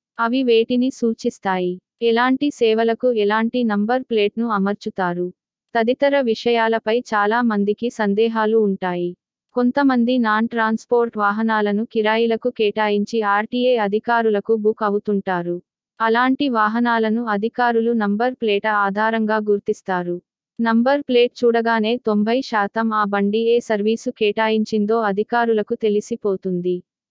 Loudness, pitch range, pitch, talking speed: -19 LUFS, 210-235 Hz, 220 Hz, 95 wpm